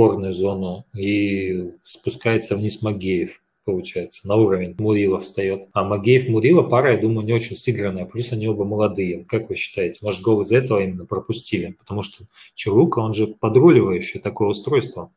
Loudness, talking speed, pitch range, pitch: -20 LUFS, 160 wpm, 95-110 Hz, 105 Hz